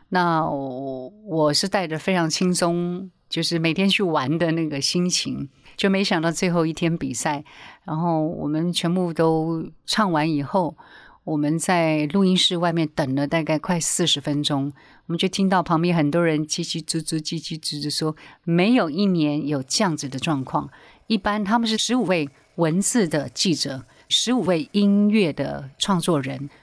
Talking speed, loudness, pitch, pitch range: 250 characters per minute, -22 LUFS, 165 Hz, 150-185 Hz